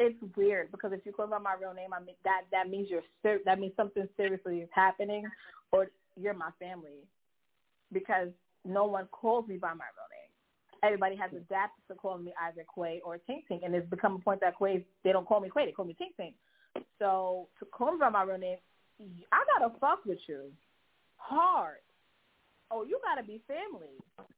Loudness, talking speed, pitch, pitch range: -33 LUFS, 205 wpm, 190 Hz, 185-210 Hz